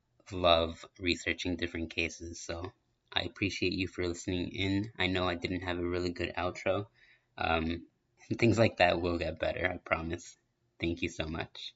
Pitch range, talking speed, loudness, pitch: 85-90 Hz, 170 wpm, -33 LUFS, 85 Hz